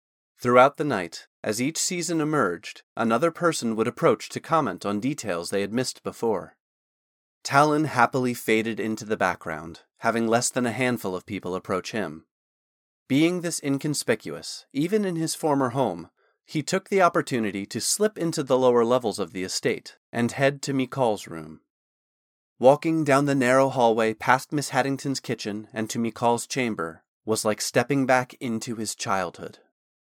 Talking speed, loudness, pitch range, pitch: 160 wpm, -24 LUFS, 110-140 Hz, 125 Hz